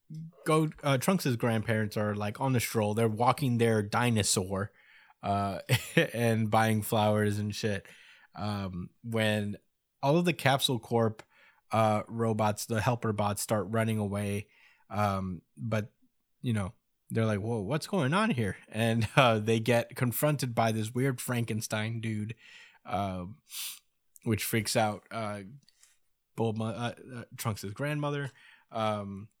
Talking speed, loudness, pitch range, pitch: 135 wpm, -30 LUFS, 105-120 Hz, 110 Hz